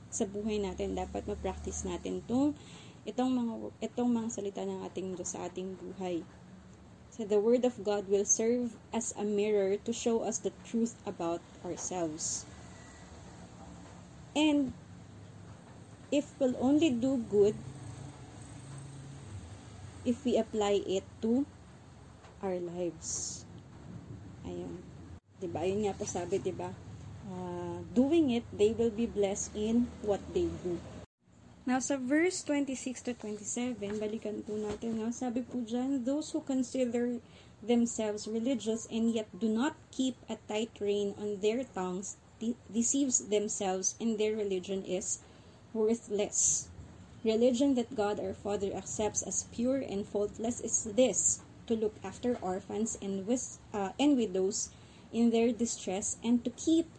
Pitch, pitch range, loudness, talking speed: 215 Hz, 190-245 Hz, -33 LUFS, 140 wpm